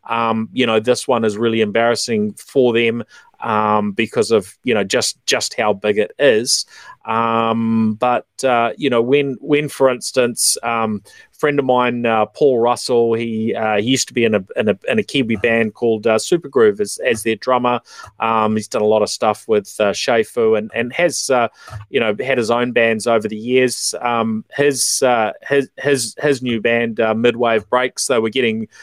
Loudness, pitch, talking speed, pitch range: -17 LUFS, 115 Hz, 200 wpm, 110-125 Hz